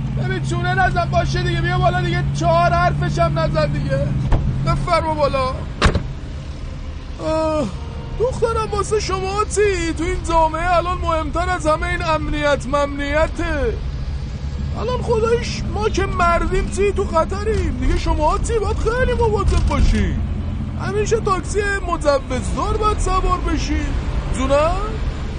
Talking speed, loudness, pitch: 125 wpm, -19 LUFS, 315 Hz